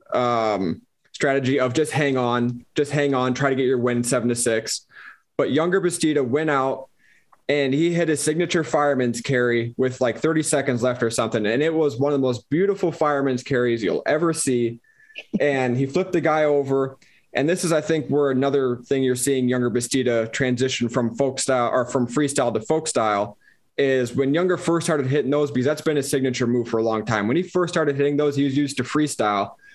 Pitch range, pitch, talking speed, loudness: 125-150 Hz, 135 Hz, 210 wpm, -22 LUFS